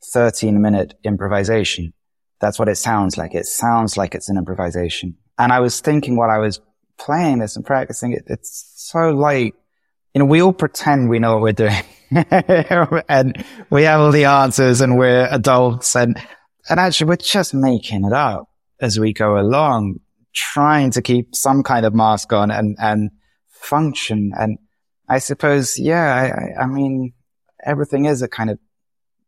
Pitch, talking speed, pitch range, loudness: 125 Hz, 170 wpm, 105-145 Hz, -16 LUFS